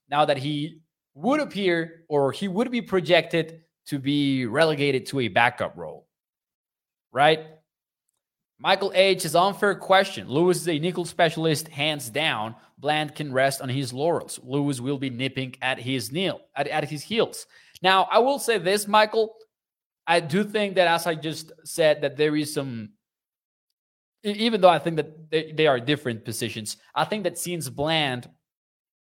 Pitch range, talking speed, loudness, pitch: 140-185 Hz, 165 wpm, -24 LUFS, 155 Hz